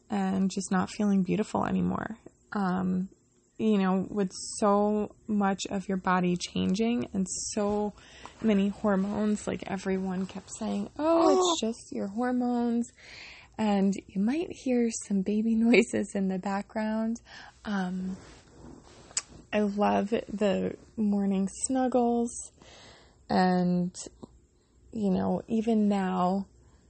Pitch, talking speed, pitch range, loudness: 205 Hz, 110 wpm, 190-220 Hz, -29 LUFS